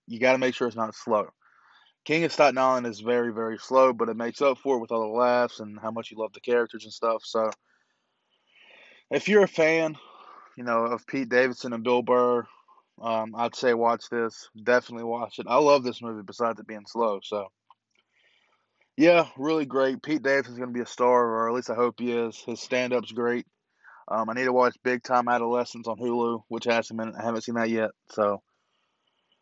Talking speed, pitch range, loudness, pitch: 210 wpm, 115-125 Hz, -26 LUFS, 120 Hz